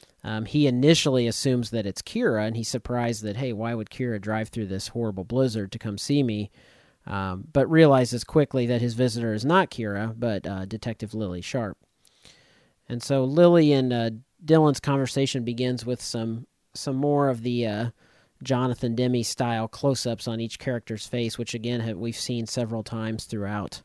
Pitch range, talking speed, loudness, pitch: 110-130 Hz, 175 wpm, -25 LUFS, 120 Hz